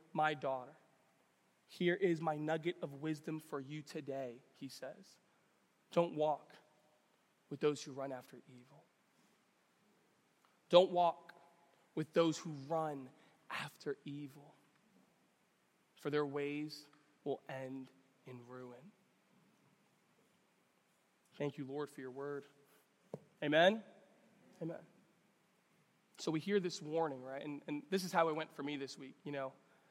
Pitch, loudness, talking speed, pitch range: 150 Hz, -39 LUFS, 125 wpm, 140-170 Hz